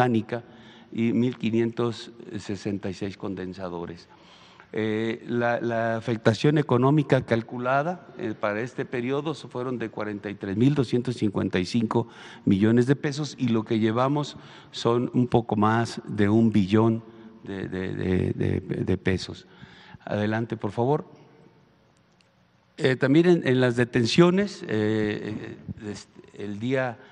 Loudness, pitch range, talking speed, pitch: -25 LUFS, 105-130 Hz, 105 wpm, 115 Hz